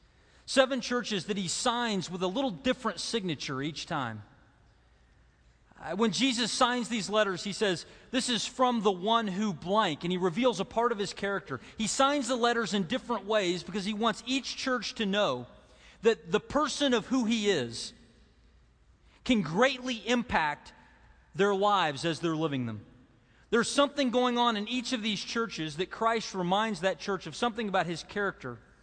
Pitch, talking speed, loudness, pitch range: 210 Hz, 175 wpm, -30 LUFS, 175-240 Hz